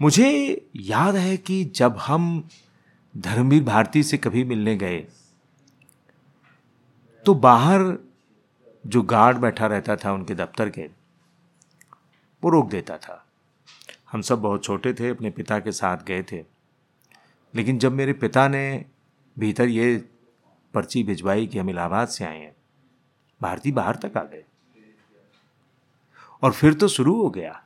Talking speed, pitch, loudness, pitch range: 135 wpm, 120 Hz, -22 LUFS, 105-155 Hz